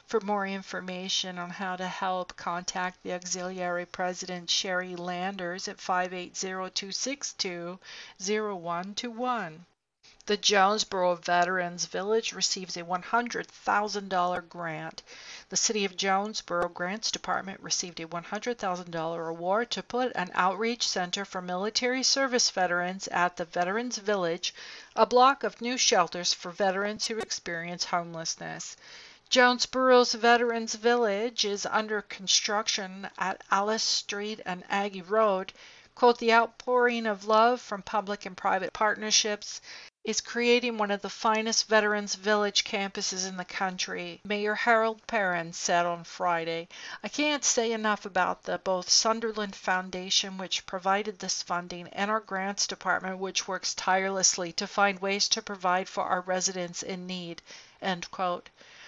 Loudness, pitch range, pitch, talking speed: -28 LUFS, 180-220 Hz, 195 Hz, 130 wpm